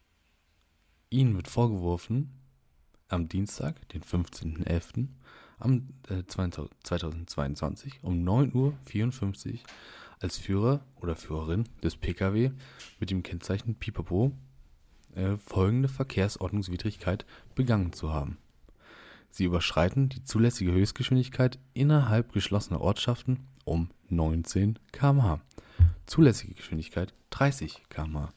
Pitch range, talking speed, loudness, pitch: 85-125 Hz, 85 wpm, -30 LUFS, 100 Hz